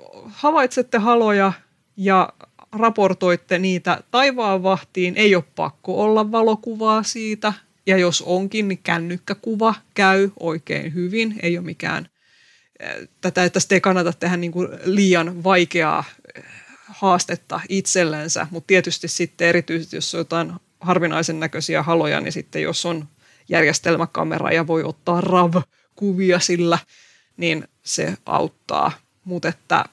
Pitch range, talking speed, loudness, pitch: 170-200 Hz, 120 wpm, -20 LUFS, 180 Hz